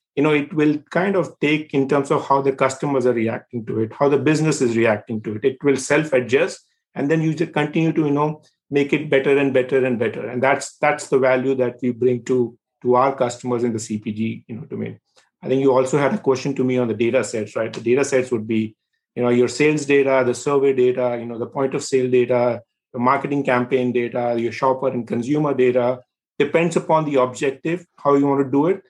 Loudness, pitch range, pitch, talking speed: -20 LUFS, 125-145 Hz, 135 Hz, 235 wpm